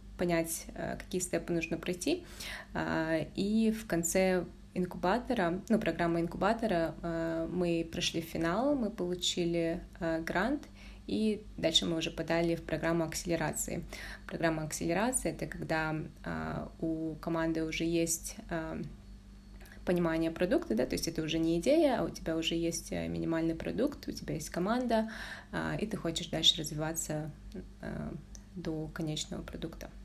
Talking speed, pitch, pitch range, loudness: 125 wpm, 165 Hz, 160-180 Hz, -33 LUFS